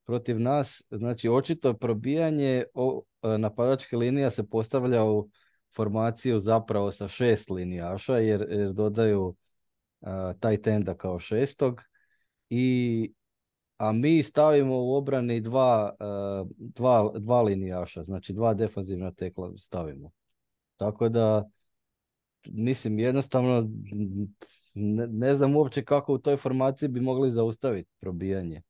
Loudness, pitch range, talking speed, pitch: -27 LUFS, 100-130 Hz, 120 wpm, 115 Hz